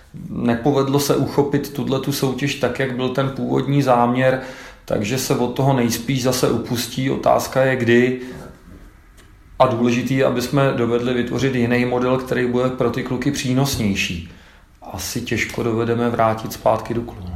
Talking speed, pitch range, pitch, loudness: 150 wpm, 115-135 Hz, 125 Hz, -19 LUFS